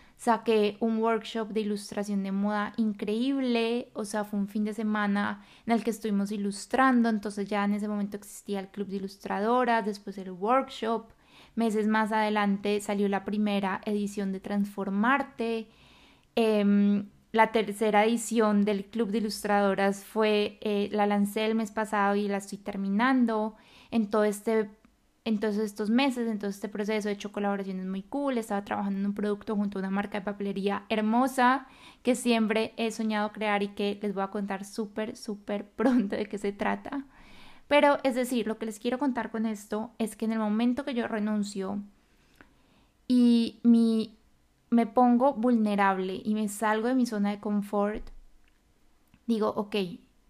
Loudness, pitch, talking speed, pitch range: -28 LUFS, 215 Hz, 165 wpm, 205-230 Hz